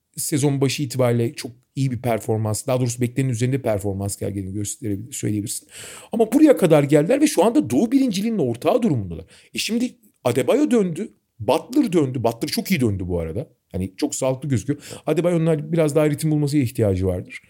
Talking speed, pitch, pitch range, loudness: 170 wpm, 135 Hz, 110-165 Hz, -21 LUFS